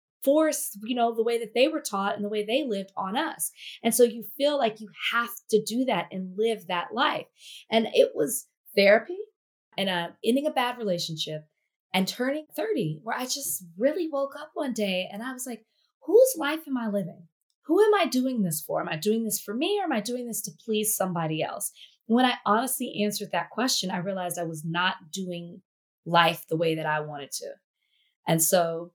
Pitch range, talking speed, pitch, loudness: 180-260 Hz, 215 wpm, 215 Hz, -26 LUFS